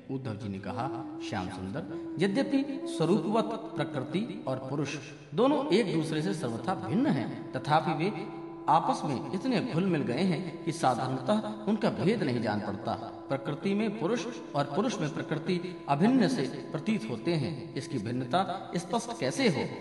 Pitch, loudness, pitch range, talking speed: 165 Hz, -31 LUFS, 135-190 Hz, 155 wpm